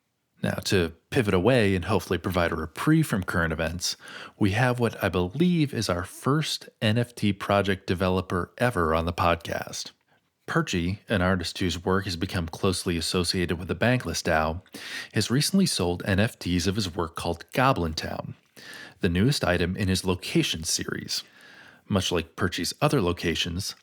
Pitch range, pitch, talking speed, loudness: 85-110 Hz, 95 Hz, 155 wpm, -26 LUFS